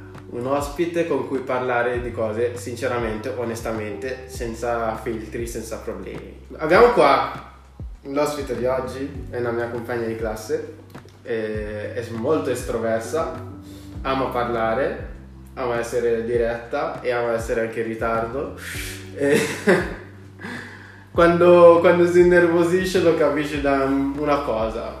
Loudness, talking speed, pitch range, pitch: -21 LUFS, 115 wpm, 110-140 Hz, 120 Hz